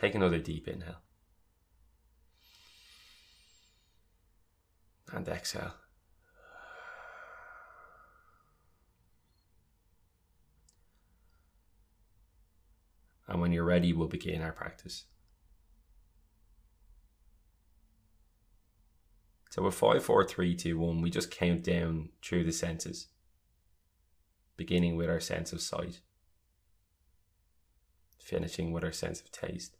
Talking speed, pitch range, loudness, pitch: 80 wpm, 80-95 Hz, -33 LUFS, 85 Hz